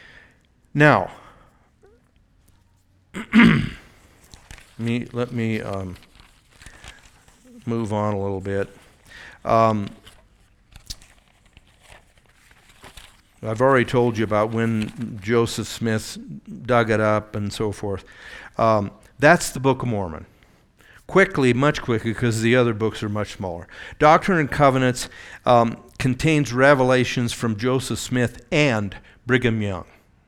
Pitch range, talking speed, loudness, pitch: 100-125 Hz, 105 wpm, -20 LUFS, 115 Hz